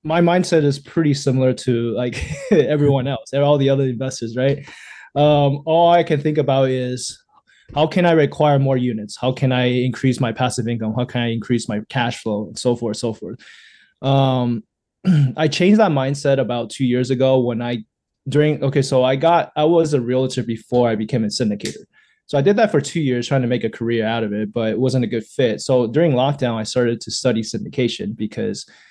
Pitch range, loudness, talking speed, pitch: 120-145 Hz, -18 LUFS, 210 wpm, 130 Hz